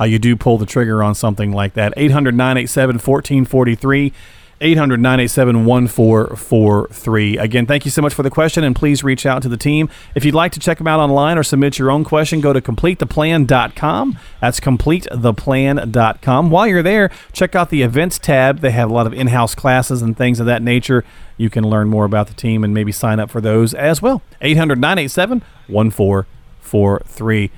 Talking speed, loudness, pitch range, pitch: 190 wpm, -14 LUFS, 115-145 Hz, 130 Hz